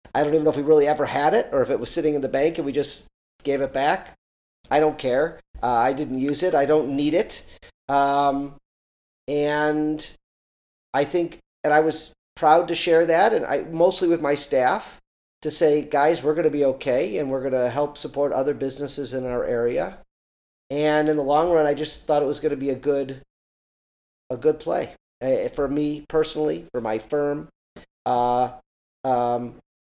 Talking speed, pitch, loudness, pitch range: 200 wpm, 145 Hz, -22 LUFS, 130-155 Hz